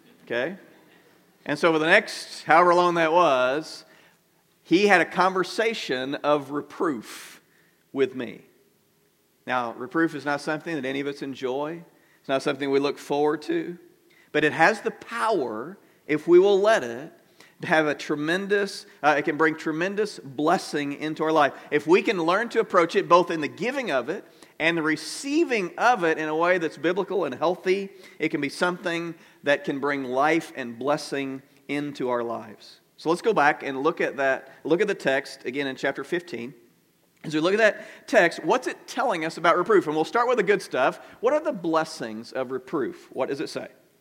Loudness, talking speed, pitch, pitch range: -24 LUFS, 190 wpm, 155 Hz, 140-175 Hz